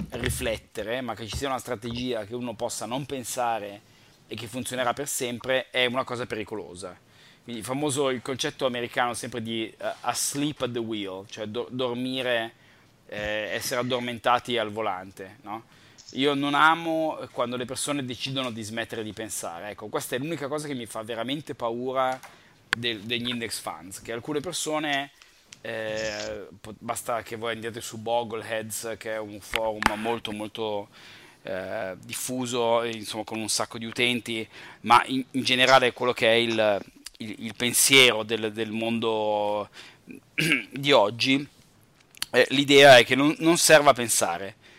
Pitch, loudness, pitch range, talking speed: 120 Hz, -25 LUFS, 110-130 Hz, 155 wpm